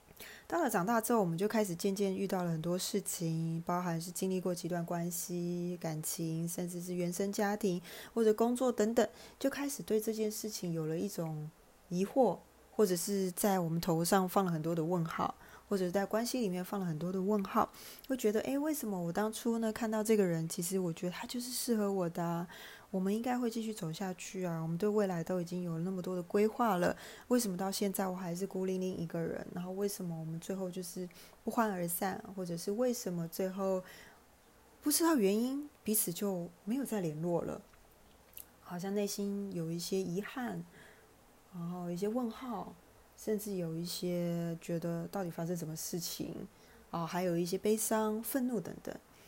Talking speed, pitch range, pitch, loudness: 290 characters per minute, 175-215 Hz, 190 Hz, -35 LUFS